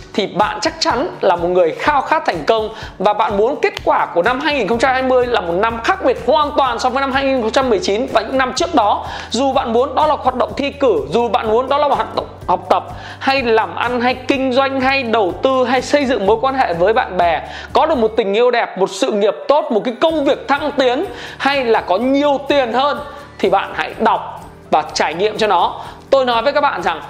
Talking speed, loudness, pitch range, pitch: 240 wpm, -16 LUFS, 225-285 Hz, 260 Hz